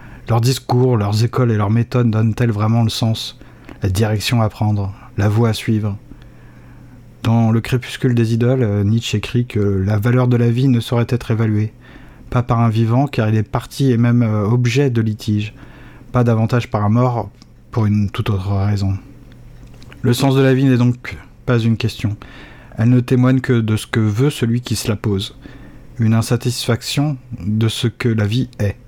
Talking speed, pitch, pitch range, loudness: 185 wpm, 115 Hz, 110-125 Hz, -17 LUFS